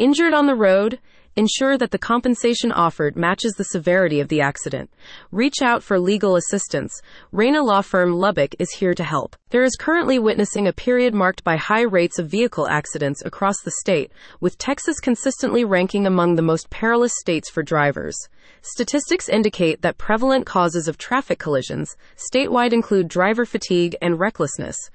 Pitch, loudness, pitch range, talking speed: 200 Hz, -19 LUFS, 175-240 Hz, 165 wpm